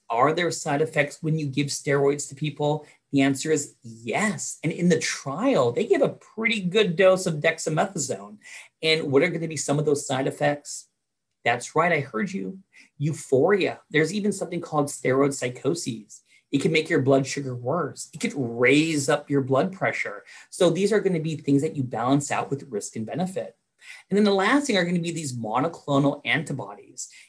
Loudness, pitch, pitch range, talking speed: -24 LUFS, 150 Hz, 140-170 Hz, 200 wpm